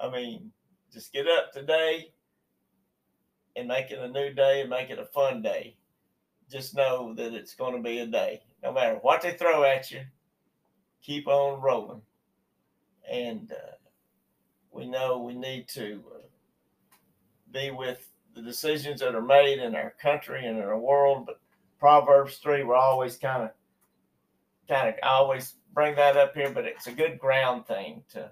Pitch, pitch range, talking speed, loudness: 135 Hz, 125-145 Hz, 170 wpm, -26 LUFS